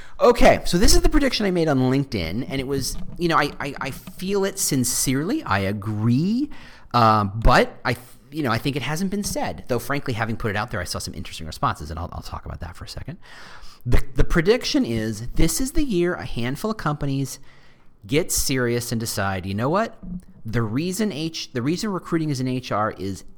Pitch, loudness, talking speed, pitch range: 130 Hz, -23 LUFS, 215 wpm, 110-165 Hz